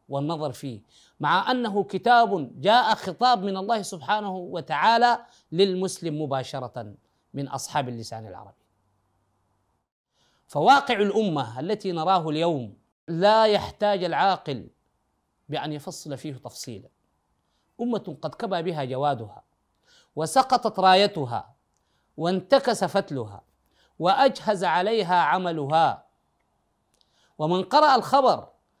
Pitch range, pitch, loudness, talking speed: 130-205 Hz, 170 Hz, -23 LUFS, 90 wpm